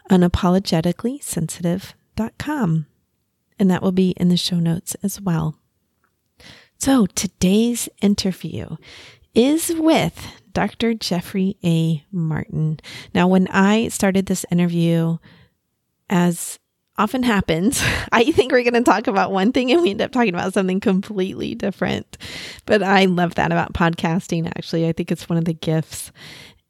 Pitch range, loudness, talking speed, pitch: 170-210 Hz, -19 LUFS, 140 wpm, 185 Hz